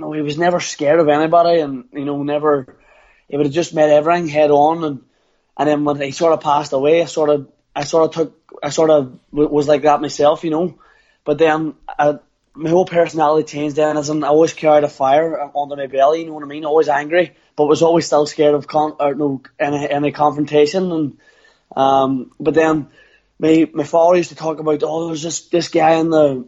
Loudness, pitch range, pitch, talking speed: -16 LUFS, 145-160 Hz, 150 Hz, 225 wpm